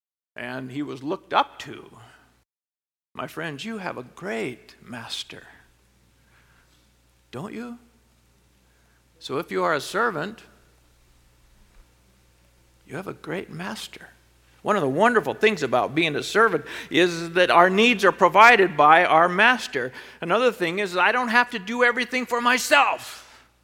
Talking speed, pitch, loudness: 140 wpm, 145 Hz, -21 LUFS